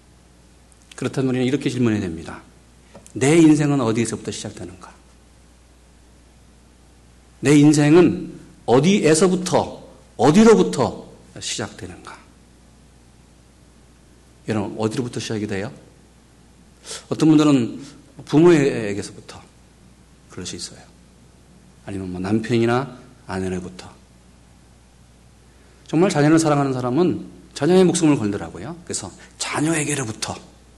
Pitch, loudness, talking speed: 95 Hz, -19 LUFS, 250 characters per minute